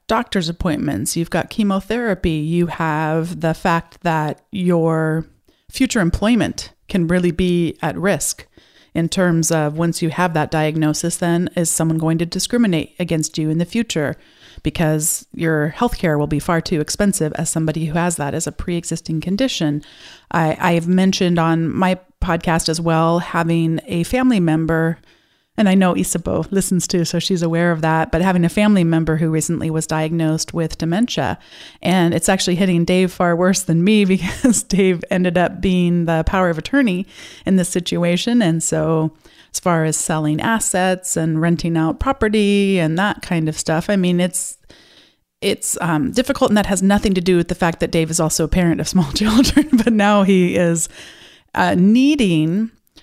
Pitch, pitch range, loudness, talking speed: 170 Hz, 160-190 Hz, -17 LUFS, 175 wpm